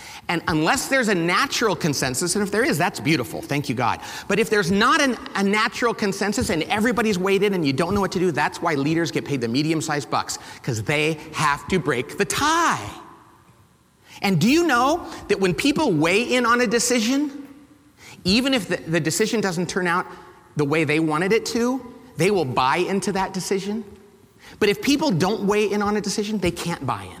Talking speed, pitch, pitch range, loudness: 210 wpm, 200 Hz, 170-235 Hz, -21 LUFS